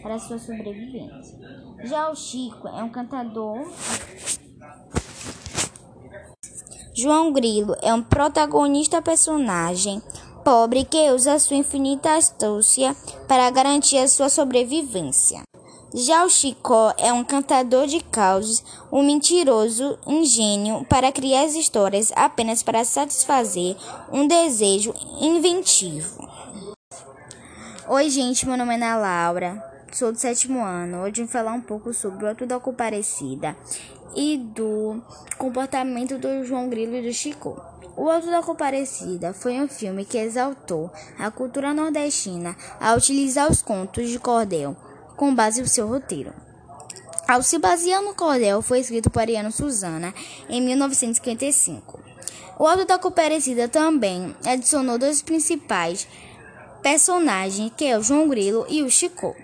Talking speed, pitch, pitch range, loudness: 130 wpm, 250 Hz, 220-285 Hz, -20 LUFS